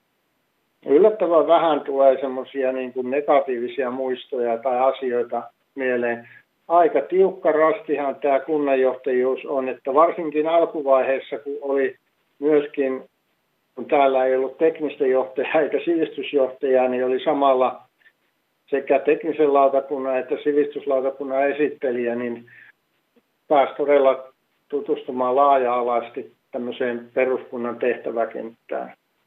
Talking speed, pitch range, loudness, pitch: 95 wpm, 130-150 Hz, -21 LUFS, 135 Hz